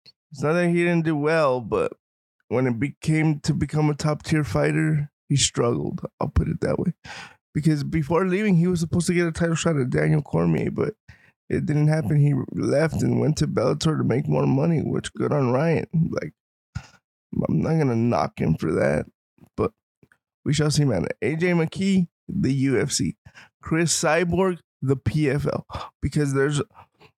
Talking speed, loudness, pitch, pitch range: 175 wpm, -23 LUFS, 155 Hz, 140-165 Hz